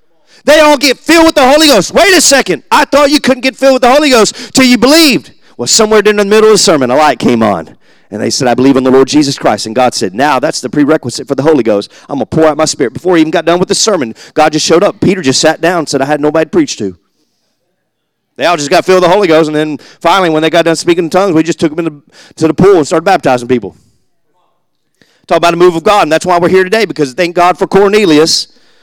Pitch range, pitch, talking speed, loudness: 155-220 Hz, 175 Hz, 285 wpm, -8 LUFS